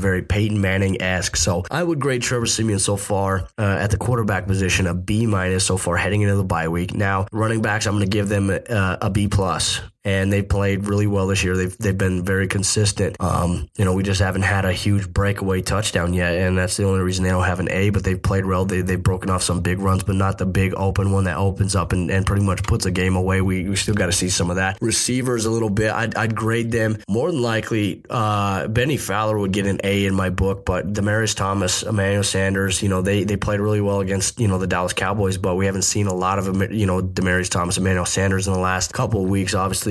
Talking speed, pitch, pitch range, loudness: 255 wpm, 95 Hz, 95-105 Hz, -20 LUFS